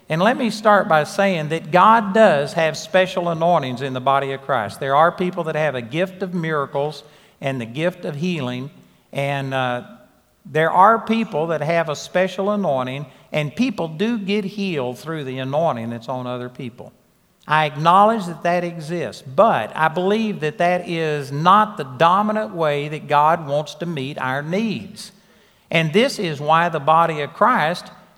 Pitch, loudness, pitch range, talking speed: 165 Hz, -19 LUFS, 145-195 Hz, 175 wpm